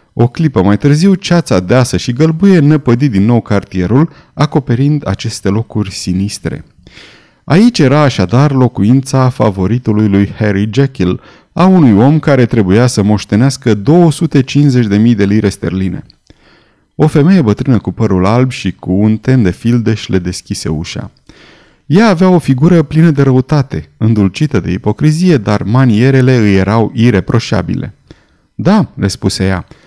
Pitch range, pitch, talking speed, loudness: 105-150 Hz, 120 Hz, 140 wpm, -10 LUFS